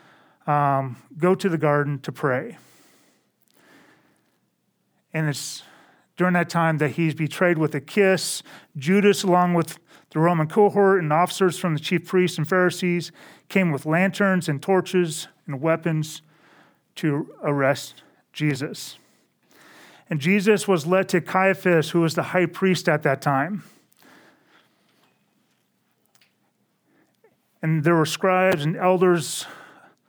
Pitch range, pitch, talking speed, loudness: 155-185 Hz, 170 Hz, 125 wpm, -22 LUFS